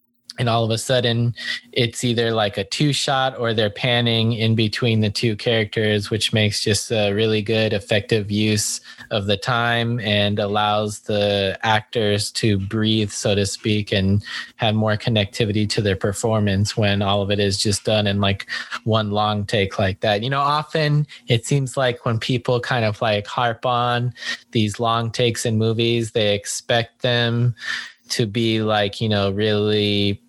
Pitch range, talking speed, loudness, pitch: 105-120 Hz, 170 wpm, -20 LUFS, 110 Hz